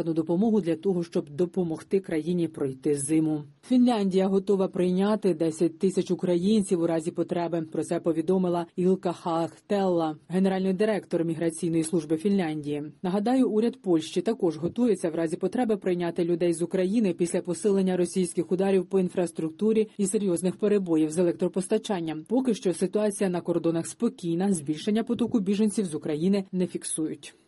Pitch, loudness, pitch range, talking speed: 180 Hz, -26 LUFS, 170-195 Hz, 140 wpm